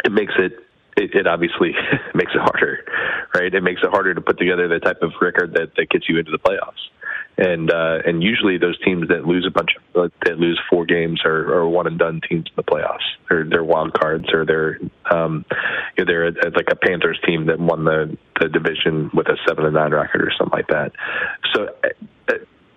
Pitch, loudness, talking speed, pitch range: 85 Hz, -18 LUFS, 220 wpm, 80-85 Hz